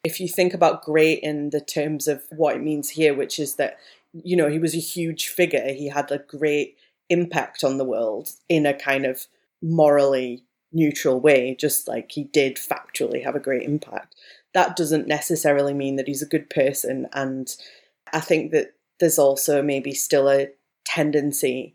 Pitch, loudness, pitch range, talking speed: 150 Hz, -22 LUFS, 140-160 Hz, 180 wpm